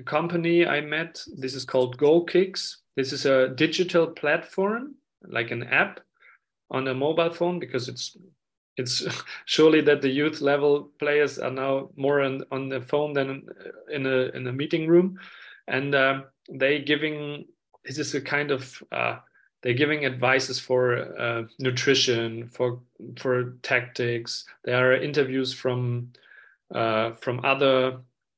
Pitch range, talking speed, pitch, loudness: 130-150 Hz, 145 wpm, 135 Hz, -25 LUFS